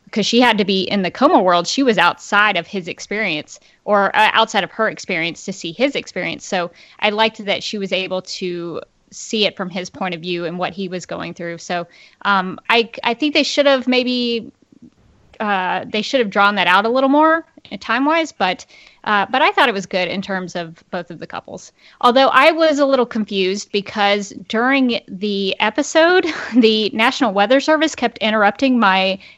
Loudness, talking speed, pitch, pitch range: -17 LUFS, 205 wpm, 210 Hz, 185-250 Hz